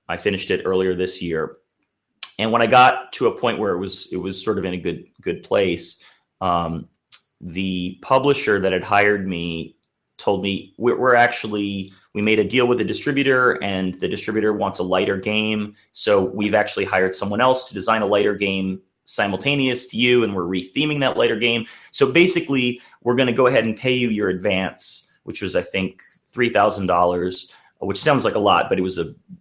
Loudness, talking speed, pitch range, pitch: -20 LUFS, 200 wpm, 95-120 Hz, 105 Hz